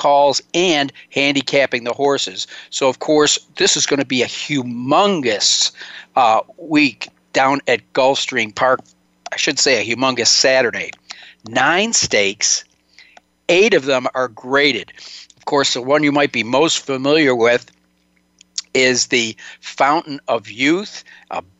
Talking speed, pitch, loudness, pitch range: 140 wpm, 130 Hz, -16 LUFS, 115-145 Hz